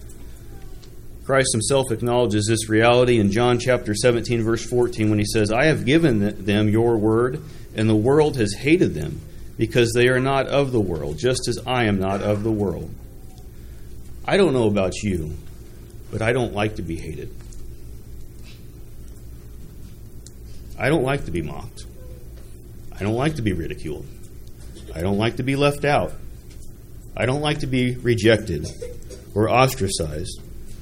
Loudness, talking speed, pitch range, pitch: -21 LUFS, 155 wpm, 100-125 Hz, 110 Hz